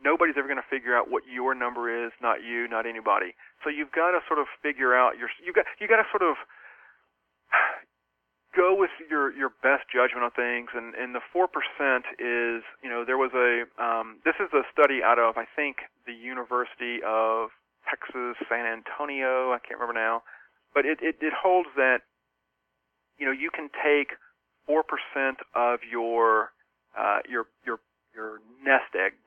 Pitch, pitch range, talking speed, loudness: 120 Hz, 115-135 Hz, 180 wpm, -26 LUFS